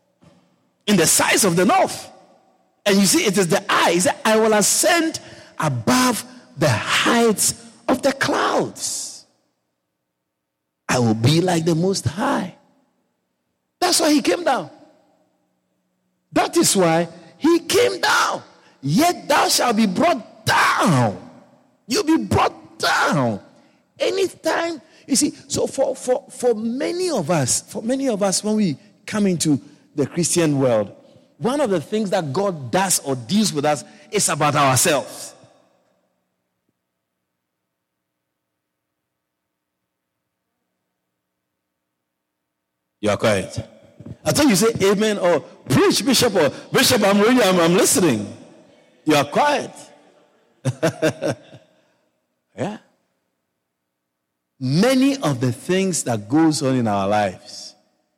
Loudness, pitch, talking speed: -19 LUFS, 160 Hz, 120 wpm